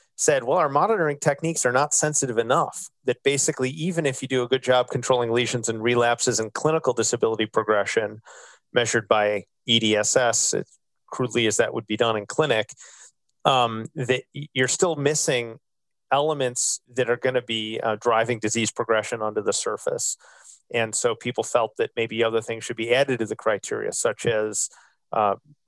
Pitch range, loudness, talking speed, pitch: 115-145 Hz, -23 LUFS, 175 wpm, 125 Hz